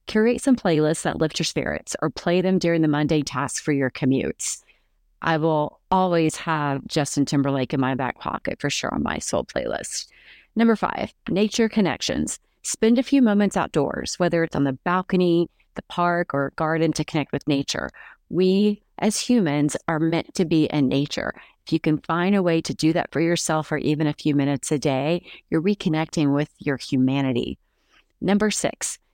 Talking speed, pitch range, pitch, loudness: 185 wpm, 145-185 Hz, 160 Hz, -23 LUFS